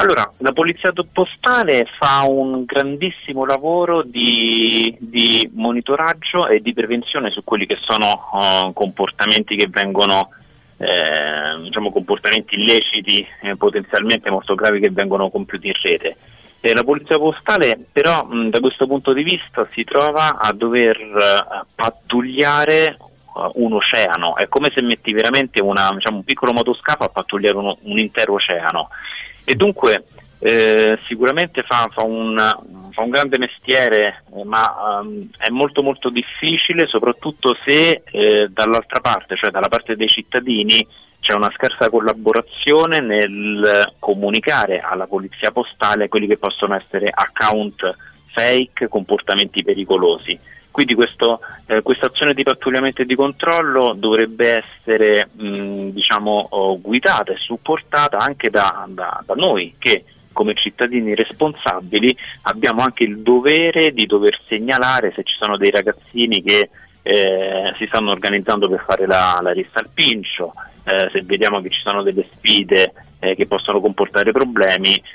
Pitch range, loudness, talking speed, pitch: 105-140 Hz, -16 LUFS, 140 wpm, 115 Hz